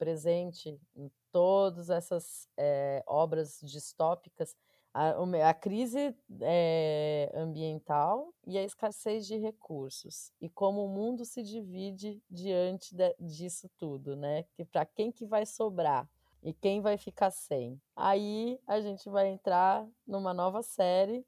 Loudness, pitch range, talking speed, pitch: -33 LUFS, 160-205 Hz, 135 wpm, 180 Hz